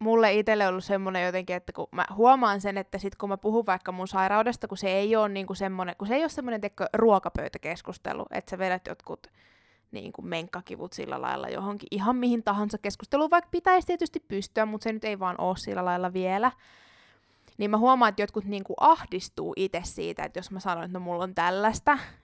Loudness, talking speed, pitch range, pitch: -27 LUFS, 205 wpm, 185-225 Hz, 205 Hz